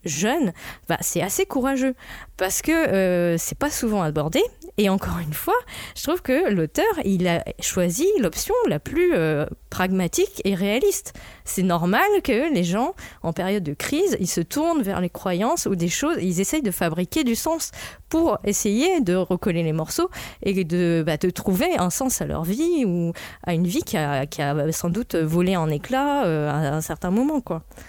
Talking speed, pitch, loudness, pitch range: 190 wpm, 190 Hz, -23 LUFS, 170-285 Hz